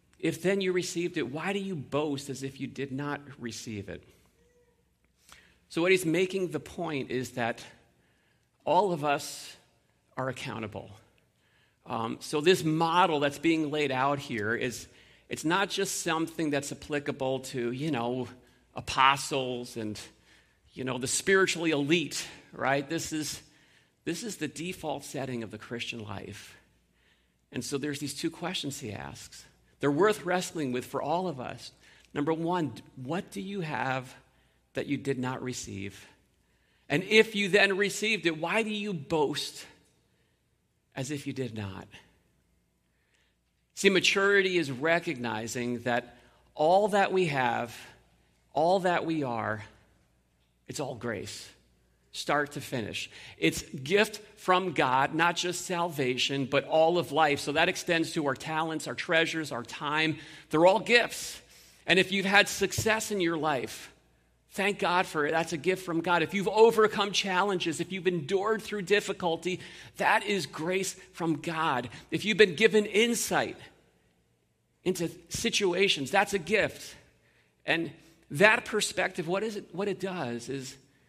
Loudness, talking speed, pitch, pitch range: -29 LUFS, 150 wpm, 155 Hz, 125-185 Hz